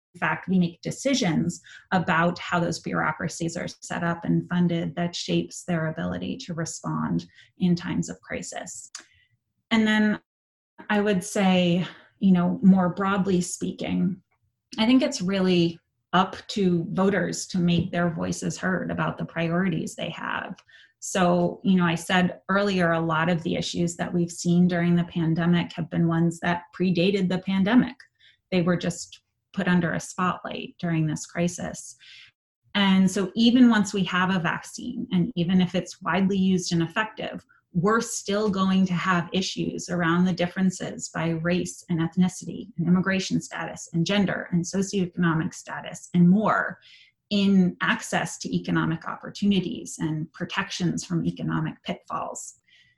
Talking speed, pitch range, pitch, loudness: 150 wpm, 170-190 Hz, 180 Hz, -25 LUFS